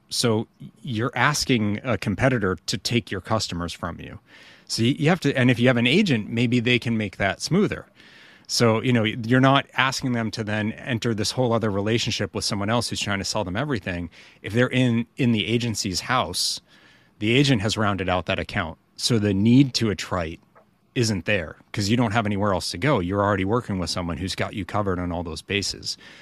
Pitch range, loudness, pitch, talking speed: 100-125 Hz, -23 LUFS, 110 Hz, 210 wpm